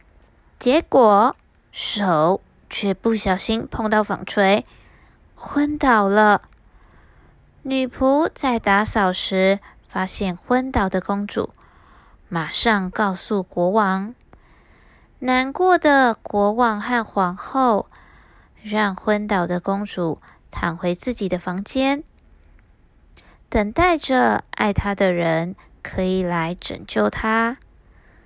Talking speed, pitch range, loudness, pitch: 140 characters per minute, 180-240 Hz, -20 LUFS, 200 Hz